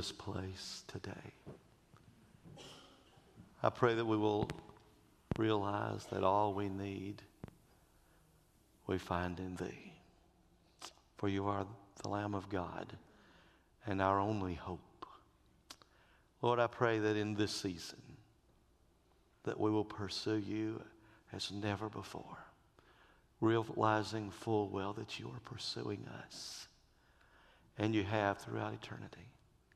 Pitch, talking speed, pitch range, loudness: 105 Hz, 110 wpm, 95-110 Hz, -39 LUFS